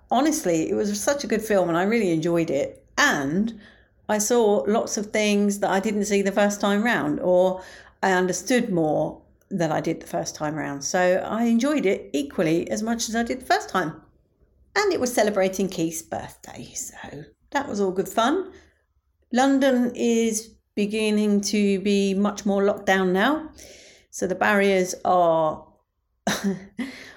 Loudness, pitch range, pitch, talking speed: -23 LUFS, 185-230 Hz, 205 Hz, 170 wpm